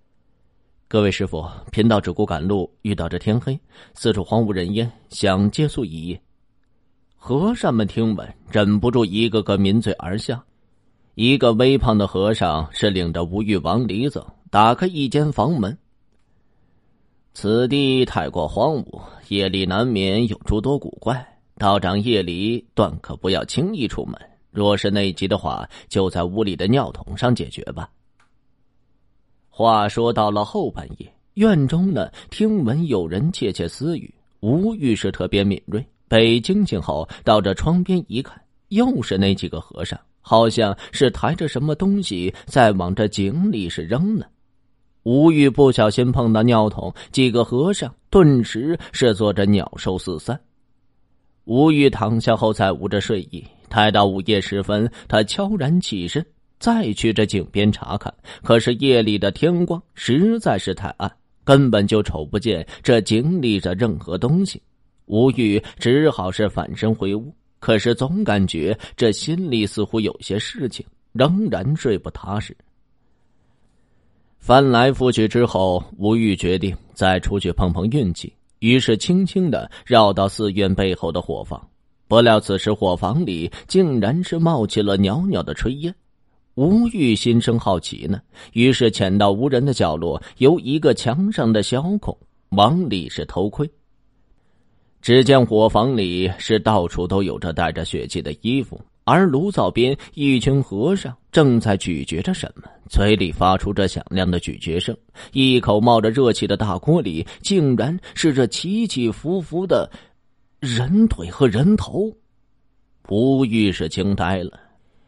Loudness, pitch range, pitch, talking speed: -19 LUFS, 100-130 Hz, 110 Hz, 220 characters per minute